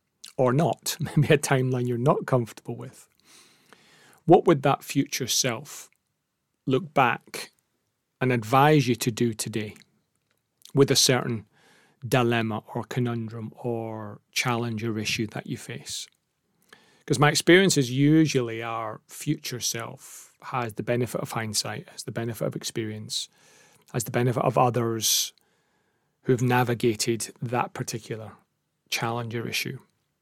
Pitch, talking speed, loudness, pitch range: 125 Hz, 130 wpm, -25 LUFS, 115-140 Hz